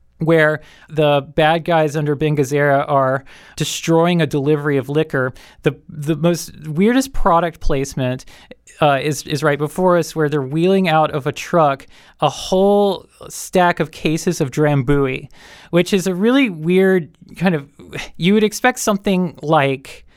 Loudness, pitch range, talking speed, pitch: -17 LUFS, 145-180 Hz, 150 wpm, 155 Hz